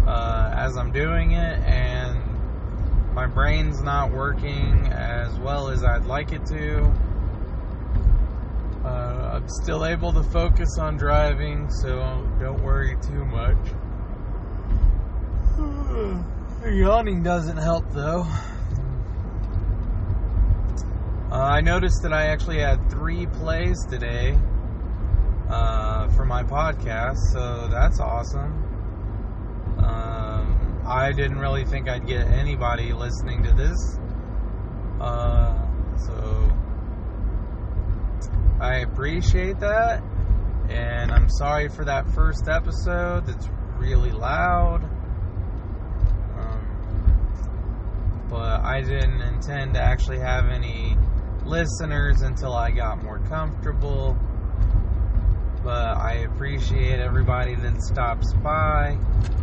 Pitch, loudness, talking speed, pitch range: 95 Hz, -25 LUFS, 100 wpm, 85-105 Hz